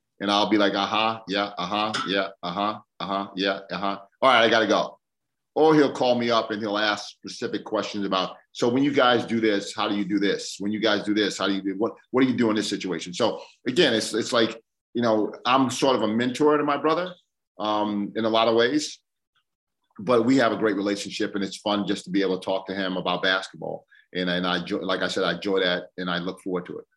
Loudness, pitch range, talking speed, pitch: -24 LUFS, 95-115 Hz, 250 wpm, 105 Hz